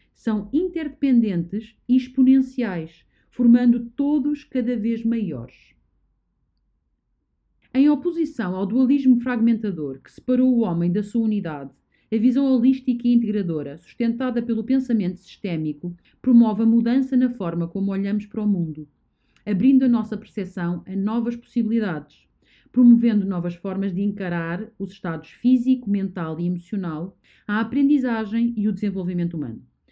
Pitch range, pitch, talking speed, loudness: 180-250 Hz, 220 Hz, 130 wpm, -22 LUFS